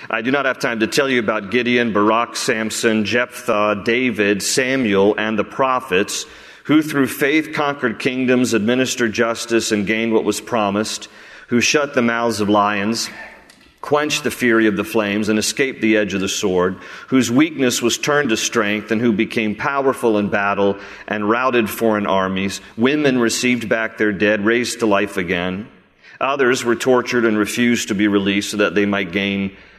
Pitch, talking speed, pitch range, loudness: 110 Hz, 175 wpm, 105-125 Hz, -18 LUFS